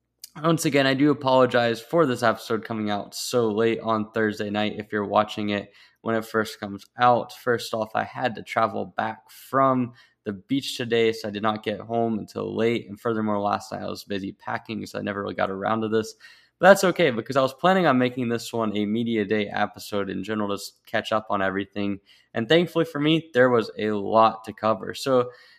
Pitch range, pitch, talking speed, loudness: 105-125 Hz, 110 Hz, 215 wpm, -24 LUFS